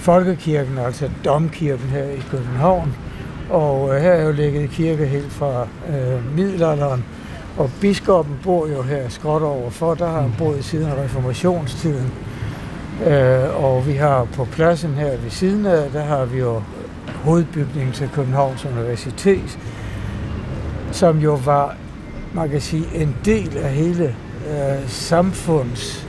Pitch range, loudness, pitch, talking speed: 130-160 Hz, -19 LUFS, 140 Hz, 140 wpm